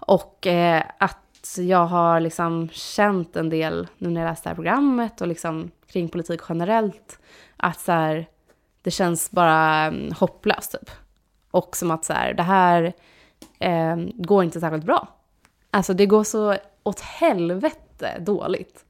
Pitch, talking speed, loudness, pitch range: 175 Hz, 150 wpm, -22 LUFS, 165-195 Hz